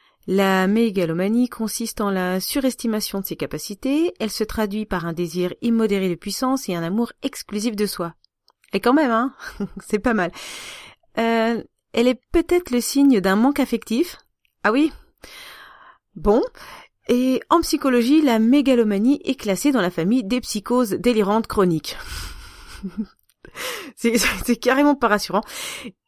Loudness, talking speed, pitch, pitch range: -21 LUFS, 145 wpm, 230 Hz, 200-260 Hz